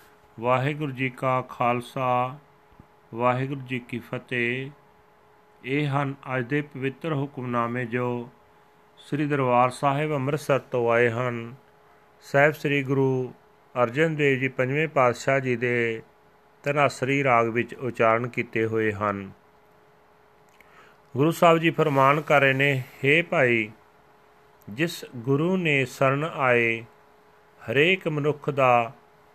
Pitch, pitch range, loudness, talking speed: 130 Hz, 120-145 Hz, -24 LUFS, 115 wpm